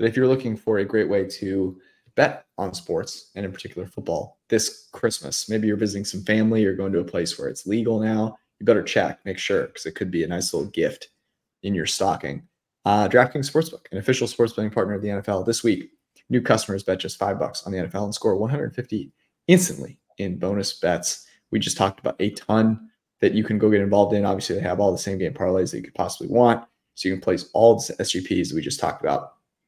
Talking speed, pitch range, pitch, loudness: 230 wpm, 95-115 Hz, 105 Hz, -23 LUFS